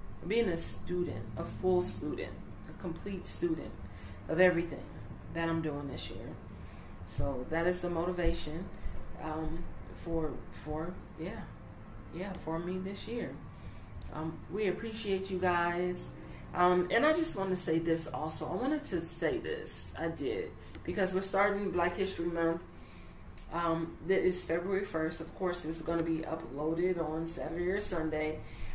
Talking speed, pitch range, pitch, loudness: 150 wpm, 145-180 Hz, 165 Hz, -35 LUFS